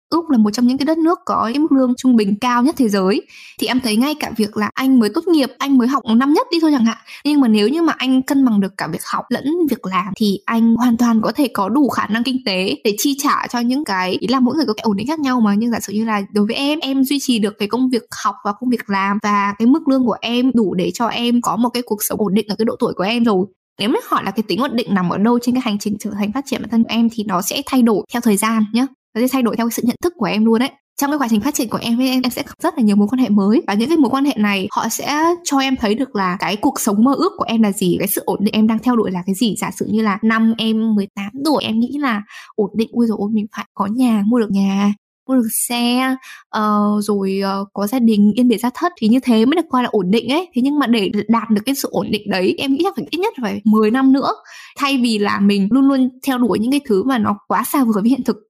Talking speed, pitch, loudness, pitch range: 315 wpm, 230 Hz, -17 LUFS, 210-265 Hz